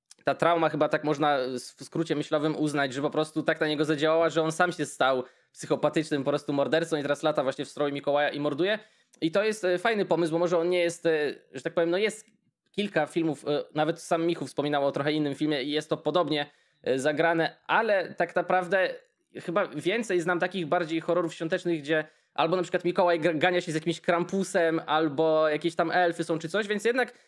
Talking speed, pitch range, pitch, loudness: 205 wpm, 150-180 Hz, 165 Hz, -27 LUFS